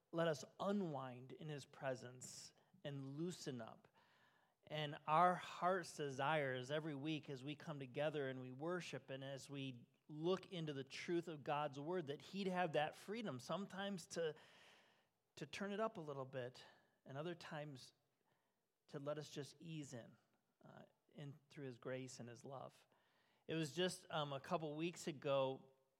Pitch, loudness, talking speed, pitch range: 150 Hz, -47 LUFS, 165 wpm, 135-170 Hz